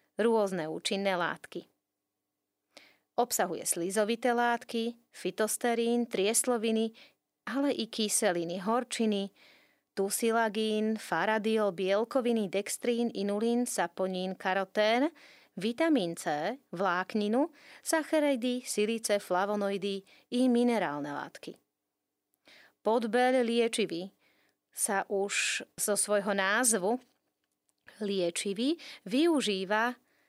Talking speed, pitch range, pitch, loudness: 75 wpm, 195-240 Hz, 220 Hz, -30 LUFS